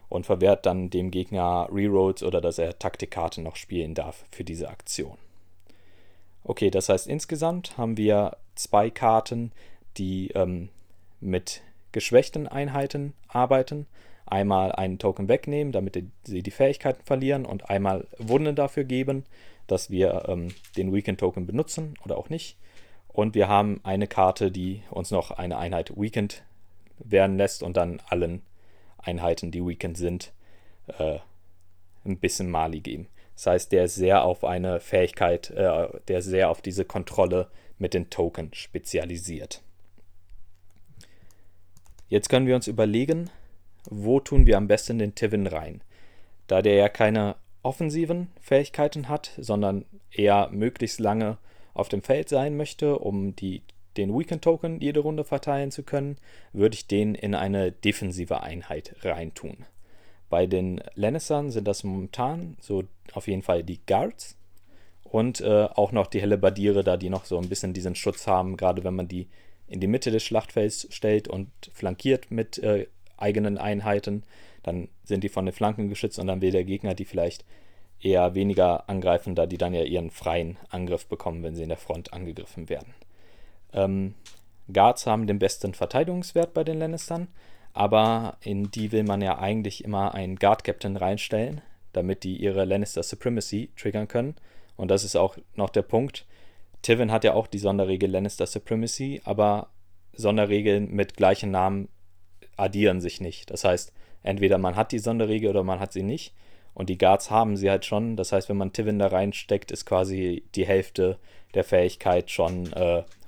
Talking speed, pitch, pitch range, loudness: 160 wpm, 100 Hz, 90-110 Hz, -26 LUFS